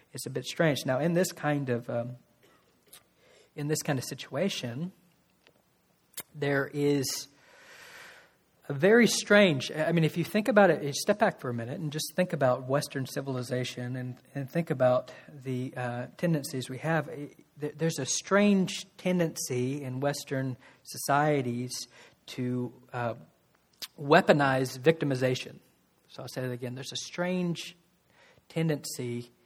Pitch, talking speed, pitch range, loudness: 145 Hz, 135 wpm, 130-165 Hz, -29 LUFS